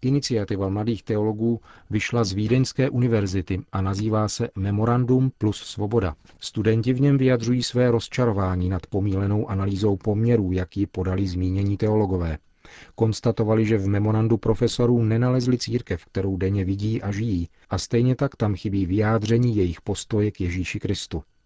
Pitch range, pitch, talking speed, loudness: 95-115 Hz, 105 Hz, 140 wpm, -23 LUFS